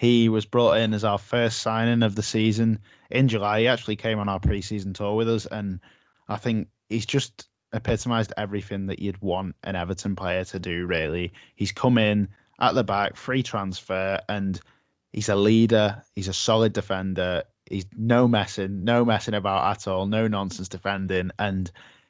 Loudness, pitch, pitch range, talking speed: -25 LUFS, 105 Hz, 95-115 Hz, 180 wpm